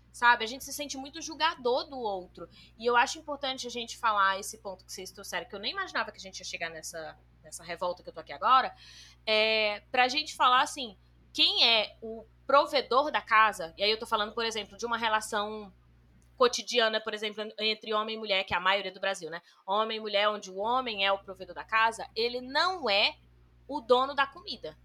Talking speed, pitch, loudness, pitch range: 220 wpm, 220 Hz, -28 LUFS, 195-250 Hz